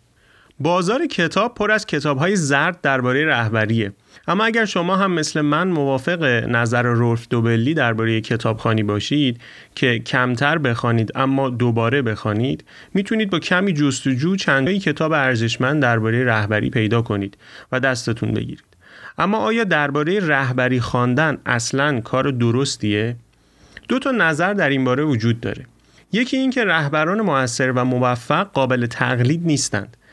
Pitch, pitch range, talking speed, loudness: 135 Hz, 120-160 Hz, 130 wpm, -19 LUFS